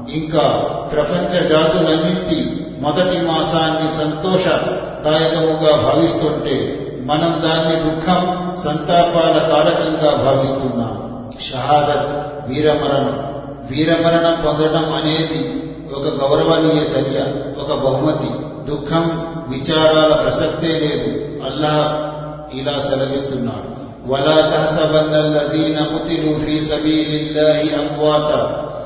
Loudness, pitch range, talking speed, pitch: -16 LUFS, 145-160 Hz, 65 wpm, 155 Hz